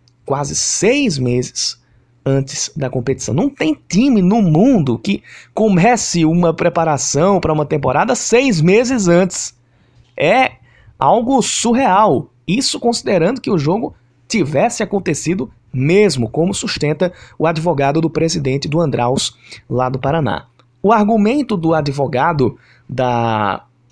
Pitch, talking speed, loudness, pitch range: 155 Hz, 120 wpm, -15 LUFS, 125-200 Hz